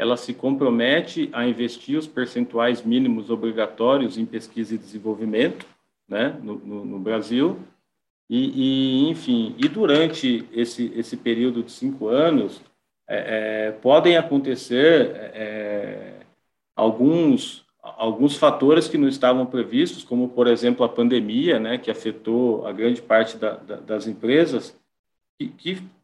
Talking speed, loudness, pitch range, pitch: 135 wpm, -21 LUFS, 115-140 Hz, 120 Hz